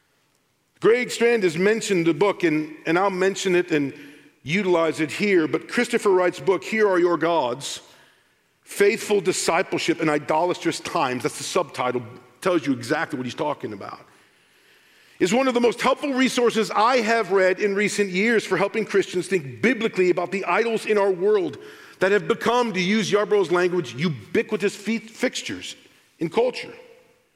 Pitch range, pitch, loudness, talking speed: 165-225 Hz, 195 Hz, -22 LUFS, 160 wpm